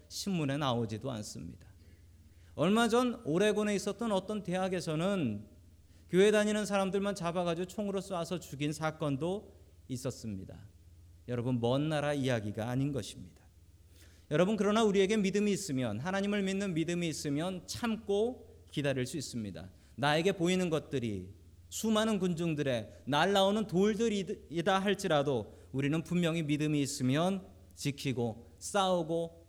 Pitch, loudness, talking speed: 150 Hz, -33 LUFS, 320 characters per minute